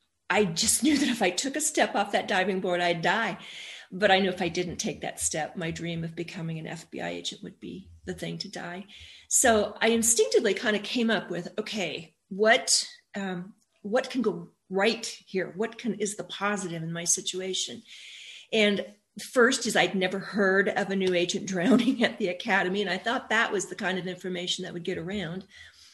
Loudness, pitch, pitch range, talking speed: -27 LUFS, 195 Hz, 180-220 Hz, 205 wpm